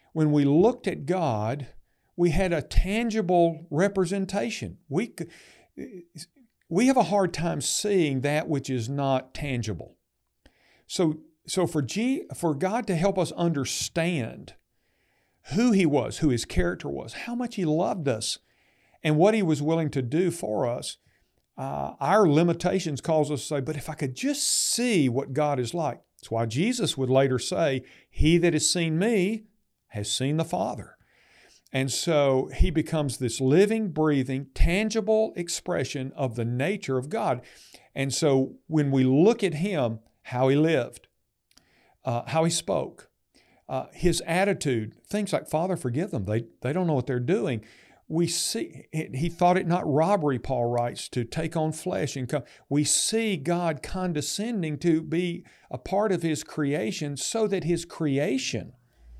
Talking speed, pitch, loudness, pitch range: 160 wpm, 160 Hz, -26 LUFS, 135-185 Hz